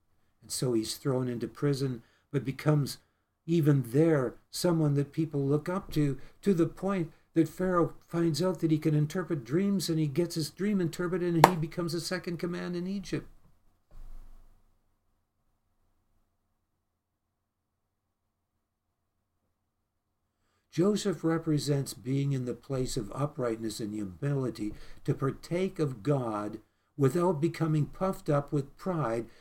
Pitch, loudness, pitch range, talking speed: 140 Hz, -30 LUFS, 105-165 Hz, 125 wpm